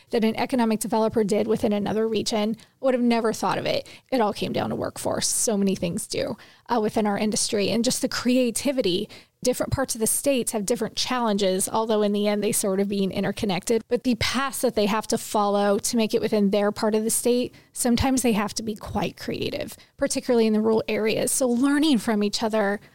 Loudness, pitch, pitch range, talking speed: -24 LUFS, 220 Hz, 210-245 Hz, 215 wpm